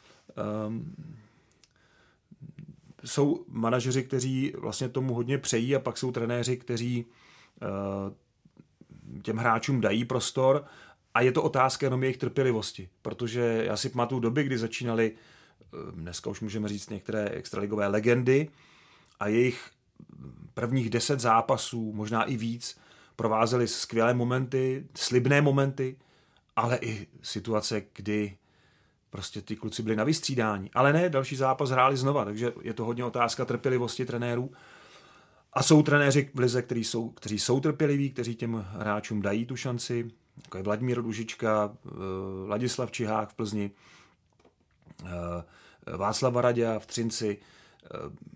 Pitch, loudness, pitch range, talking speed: 120 Hz, -28 LUFS, 110-130 Hz, 130 wpm